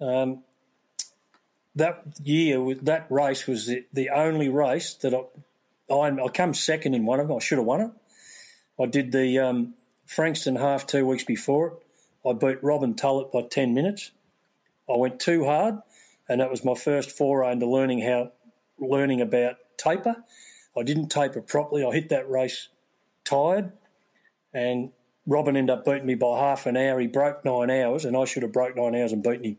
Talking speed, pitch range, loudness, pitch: 180 wpm, 125-150 Hz, -25 LUFS, 135 Hz